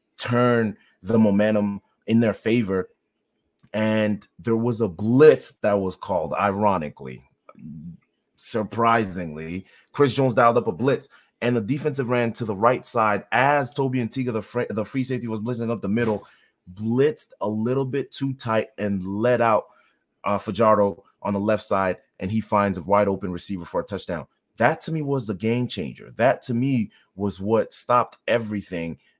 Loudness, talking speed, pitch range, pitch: -23 LUFS, 165 wpm, 100-120 Hz, 110 Hz